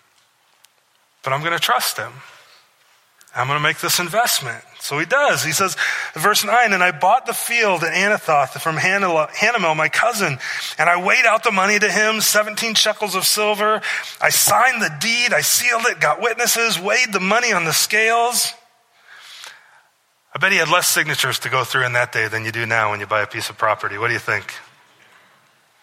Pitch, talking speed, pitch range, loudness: 190 Hz, 195 wpm, 145-215 Hz, -17 LUFS